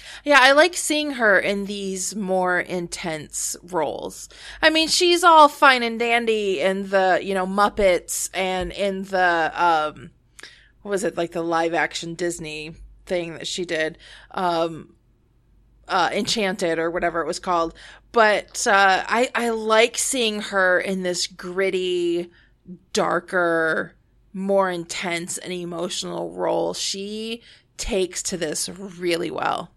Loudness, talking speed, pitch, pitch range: -21 LUFS, 135 wpm, 185 Hz, 170-210 Hz